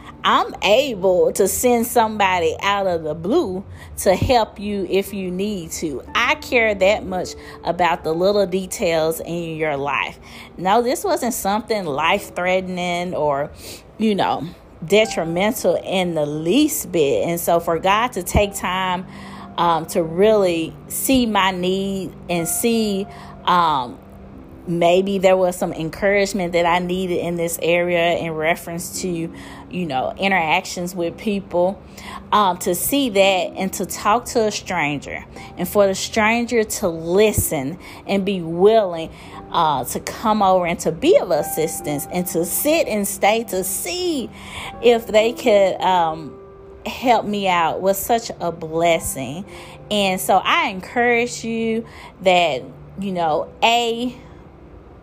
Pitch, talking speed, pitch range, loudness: 190 Hz, 145 wpm, 170-215 Hz, -19 LUFS